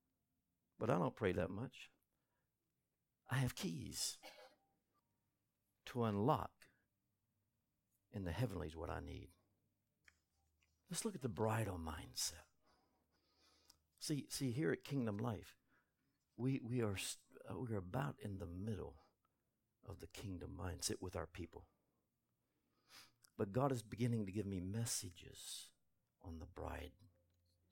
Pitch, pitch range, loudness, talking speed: 100 Hz, 85-120 Hz, -44 LUFS, 125 wpm